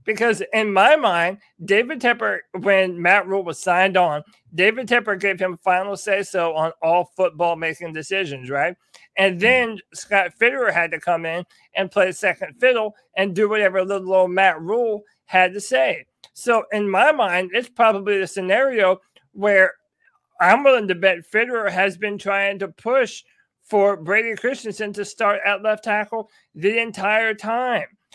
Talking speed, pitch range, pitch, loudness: 165 wpm, 185-220 Hz, 200 Hz, -19 LUFS